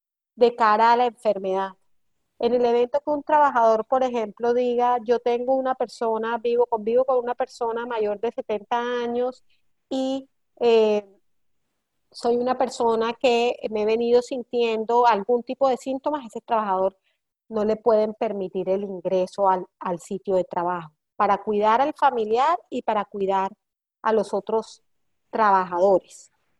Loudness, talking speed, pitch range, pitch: -23 LUFS, 145 wpm, 205-245 Hz, 230 Hz